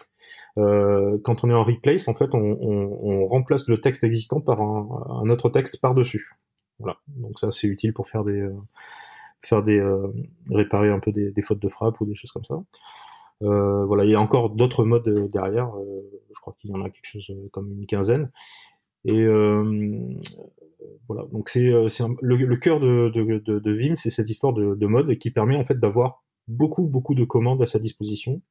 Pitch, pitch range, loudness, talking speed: 110 Hz, 105-125 Hz, -22 LUFS, 210 wpm